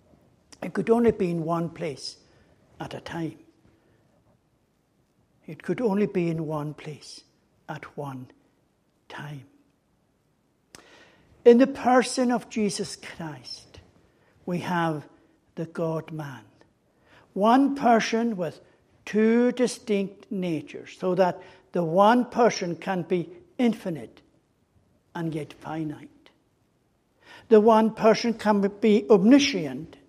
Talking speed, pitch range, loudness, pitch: 105 wpm, 165-225 Hz, -24 LUFS, 190 Hz